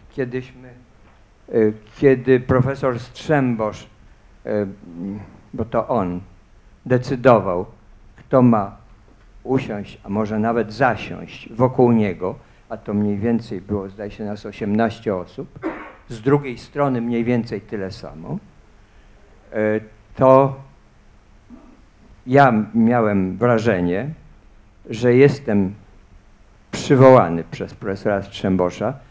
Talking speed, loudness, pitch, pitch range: 90 wpm, -19 LUFS, 110 Hz, 100-125 Hz